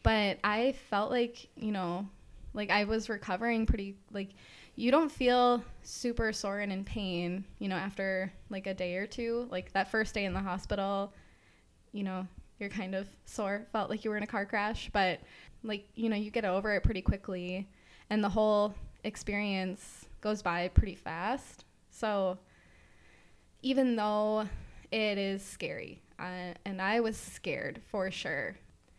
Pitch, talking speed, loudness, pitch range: 205 Hz, 165 wpm, -34 LUFS, 190-220 Hz